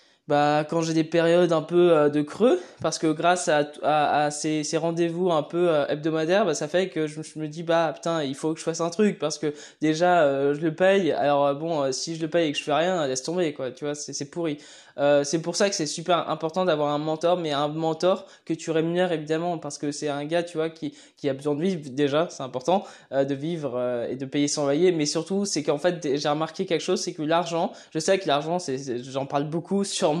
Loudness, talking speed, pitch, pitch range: -25 LUFS, 260 wpm, 160 Hz, 145-170 Hz